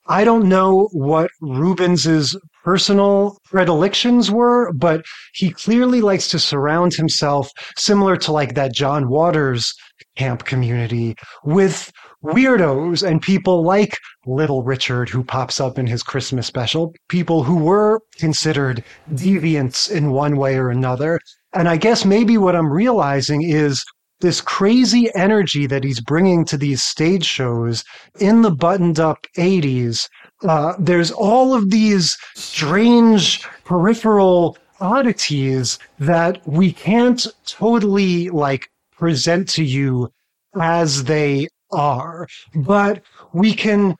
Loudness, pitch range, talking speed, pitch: -16 LUFS, 140-195 Hz, 125 wpm, 170 Hz